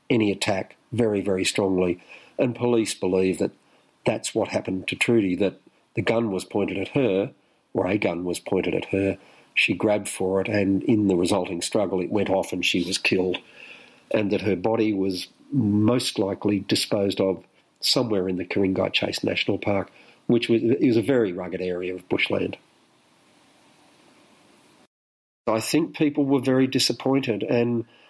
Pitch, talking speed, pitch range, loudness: 100 Hz, 165 wpm, 95-115 Hz, -24 LUFS